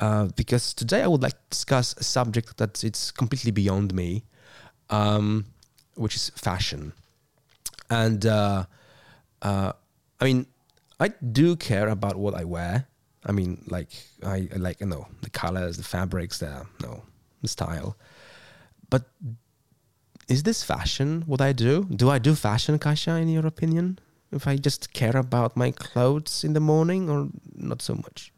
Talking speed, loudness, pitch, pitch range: 160 wpm, -25 LUFS, 120 Hz, 105-140 Hz